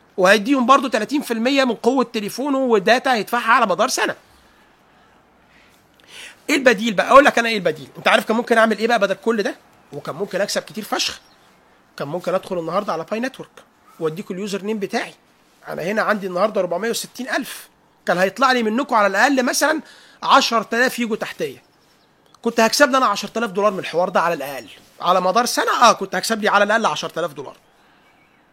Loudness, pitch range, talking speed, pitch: -18 LUFS, 195-255 Hz, 170 wpm, 225 Hz